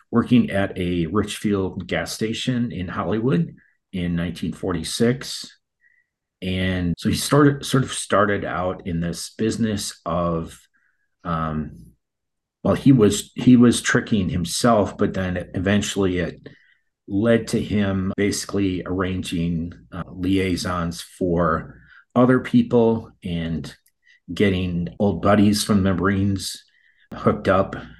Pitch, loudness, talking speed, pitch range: 95 Hz, -21 LUFS, 115 wpm, 90-110 Hz